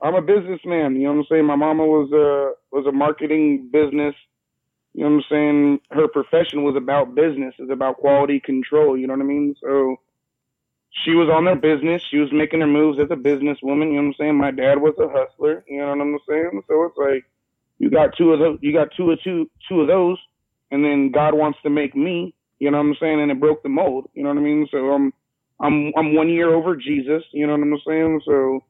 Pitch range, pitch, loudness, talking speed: 140-155 Hz, 150 Hz, -19 LUFS, 245 wpm